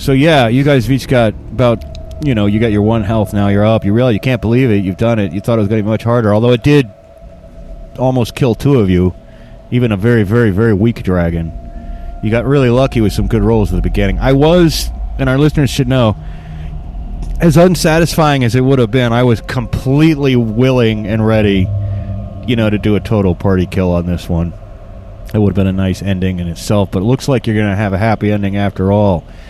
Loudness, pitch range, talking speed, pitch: -13 LUFS, 95-125 Hz, 235 wpm, 110 Hz